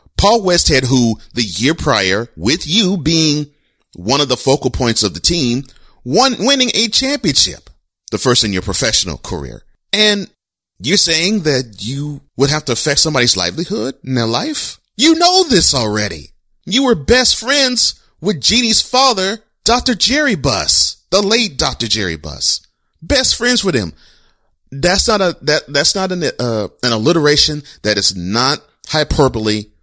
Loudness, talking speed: -13 LUFS, 155 wpm